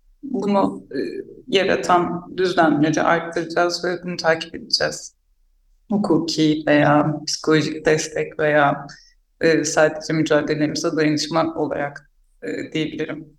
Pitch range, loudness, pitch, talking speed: 150-175 Hz, -20 LUFS, 155 Hz, 100 wpm